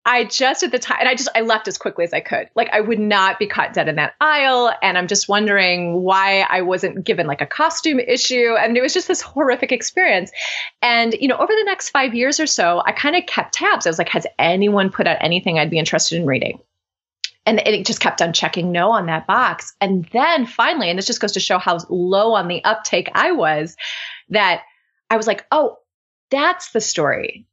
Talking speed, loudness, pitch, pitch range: 230 wpm, -17 LUFS, 225 Hz, 190-260 Hz